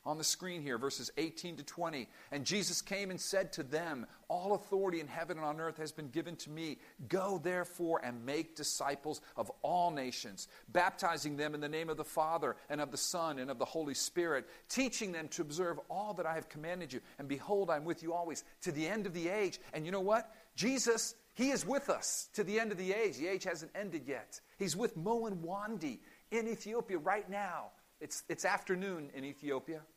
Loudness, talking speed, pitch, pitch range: -38 LUFS, 215 wpm, 170 Hz, 150-195 Hz